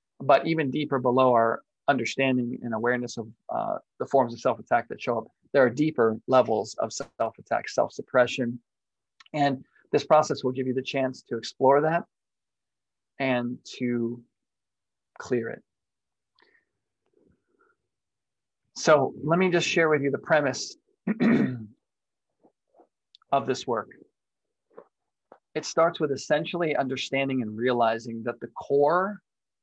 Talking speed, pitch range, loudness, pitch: 130 wpm, 120-150 Hz, -26 LUFS, 130 Hz